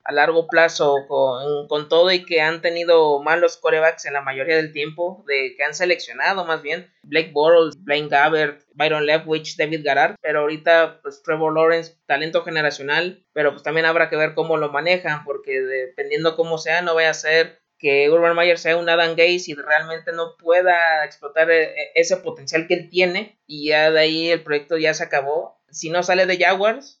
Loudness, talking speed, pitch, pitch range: -19 LUFS, 190 wpm, 160 Hz, 150-170 Hz